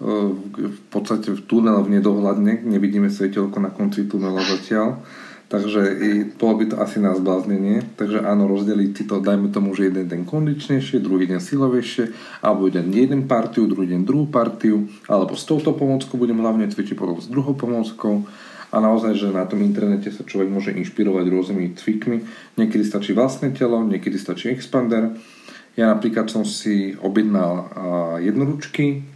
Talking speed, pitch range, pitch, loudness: 160 wpm, 100-115 Hz, 105 Hz, -20 LUFS